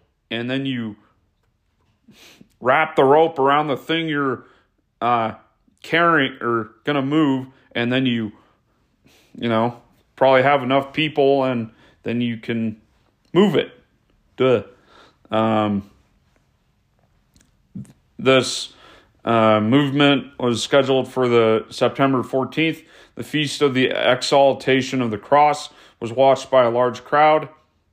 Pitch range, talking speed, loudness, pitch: 115-140 Hz, 120 wpm, -19 LUFS, 130 Hz